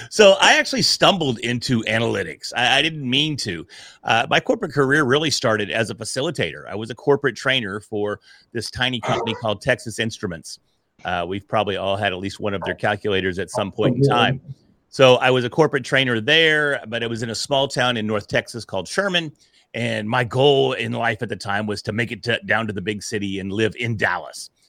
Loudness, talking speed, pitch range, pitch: -20 LUFS, 215 wpm, 105-135 Hz, 115 Hz